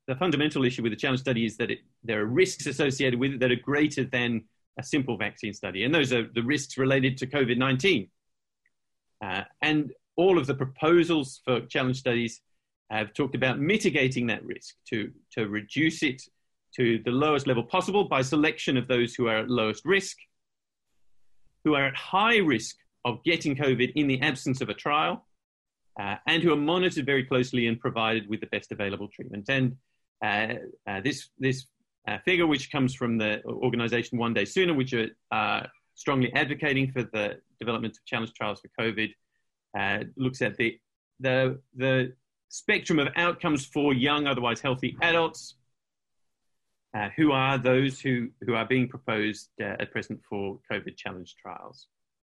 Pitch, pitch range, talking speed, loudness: 130 Hz, 115-145 Hz, 175 wpm, -27 LUFS